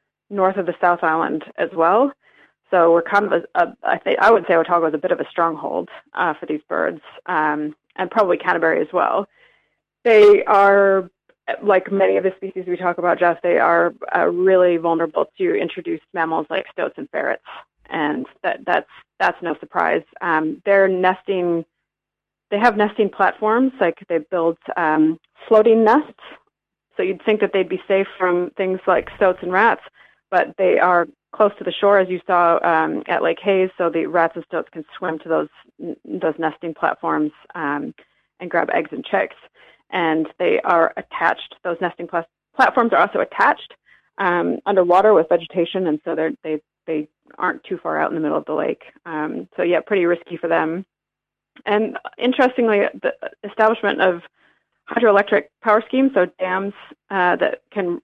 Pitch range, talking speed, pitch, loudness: 165-200 Hz, 180 wpm, 185 Hz, -19 LUFS